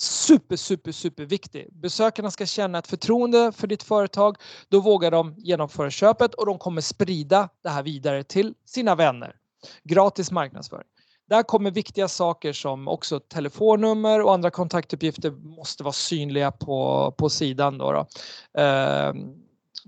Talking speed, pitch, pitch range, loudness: 145 wpm, 180 Hz, 150-205 Hz, -23 LUFS